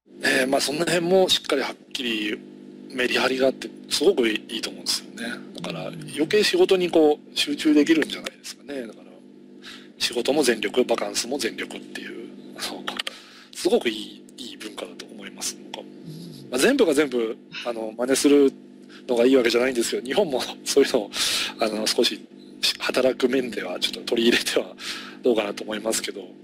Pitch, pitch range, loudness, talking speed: 135 Hz, 125-175 Hz, -23 LUFS, 370 characters per minute